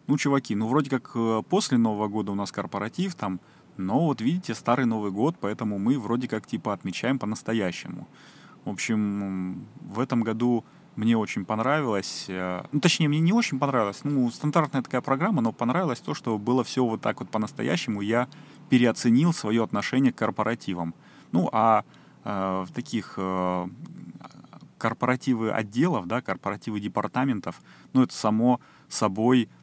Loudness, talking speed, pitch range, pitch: -26 LUFS, 150 wpm, 105-130 Hz, 115 Hz